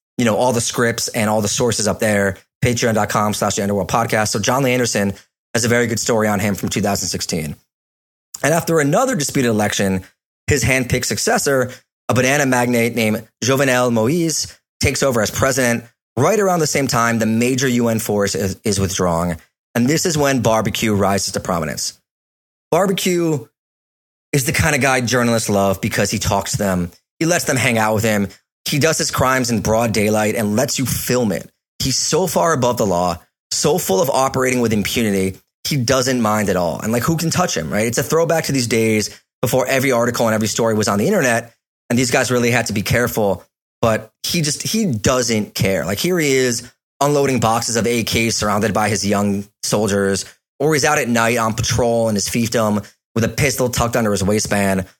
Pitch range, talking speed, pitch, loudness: 105-130 Hz, 195 wpm, 115 Hz, -17 LUFS